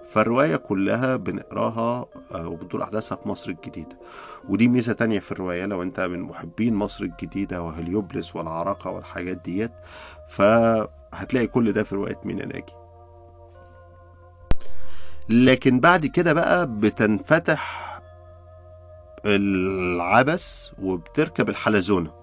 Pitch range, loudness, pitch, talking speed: 90-110 Hz, -23 LUFS, 100 Hz, 105 wpm